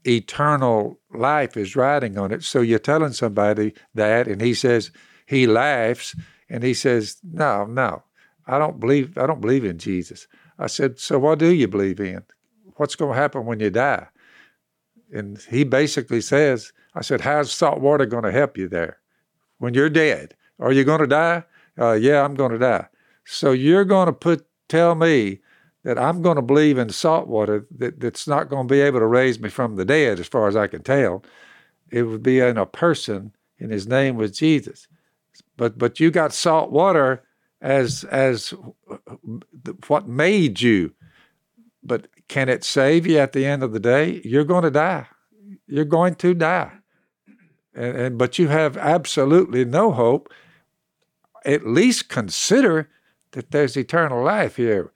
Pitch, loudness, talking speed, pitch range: 135 Hz, -19 LUFS, 180 wpm, 120-155 Hz